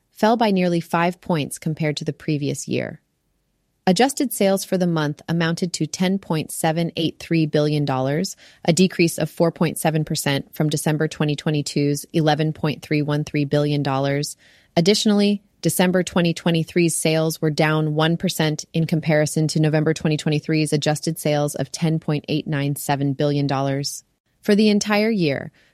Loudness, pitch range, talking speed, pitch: -21 LUFS, 150-175 Hz, 115 wpm, 160 Hz